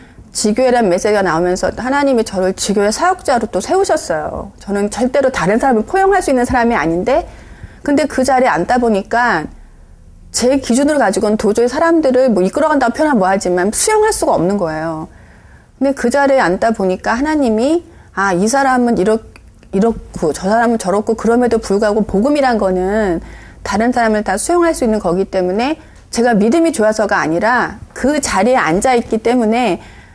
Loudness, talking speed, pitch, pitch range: -14 LUFS, 380 characters per minute, 230 Hz, 195-265 Hz